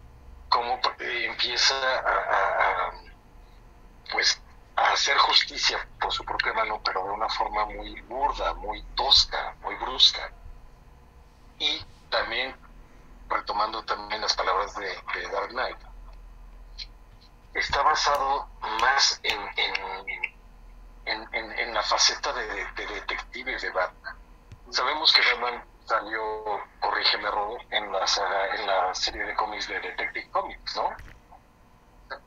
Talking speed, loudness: 115 wpm, -25 LUFS